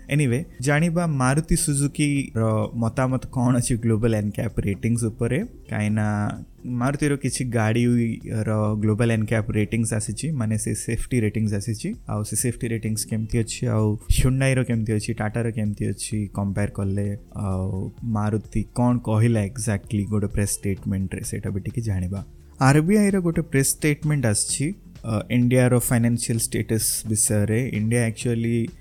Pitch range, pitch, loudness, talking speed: 105-125 Hz, 115 Hz, -23 LUFS, 130 wpm